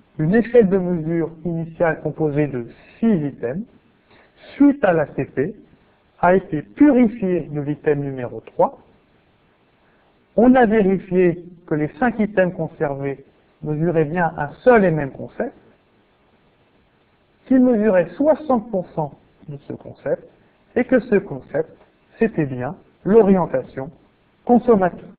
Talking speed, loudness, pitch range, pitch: 115 wpm, -19 LUFS, 150-225 Hz, 175 Hz